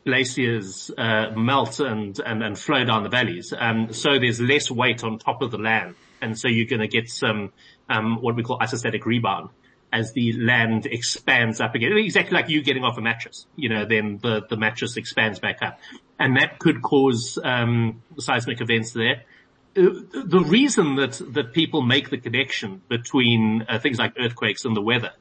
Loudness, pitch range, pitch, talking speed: -22 LUFS, 110-135 Hz, 115 Hz, 190 wpm